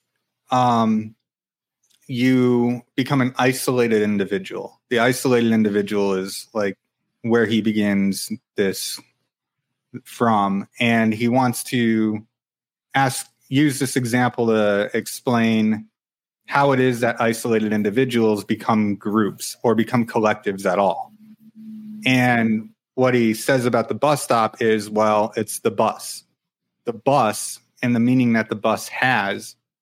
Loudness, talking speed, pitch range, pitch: -20 LUFS, 125 wpm, 110-125 Hz, 115 Hz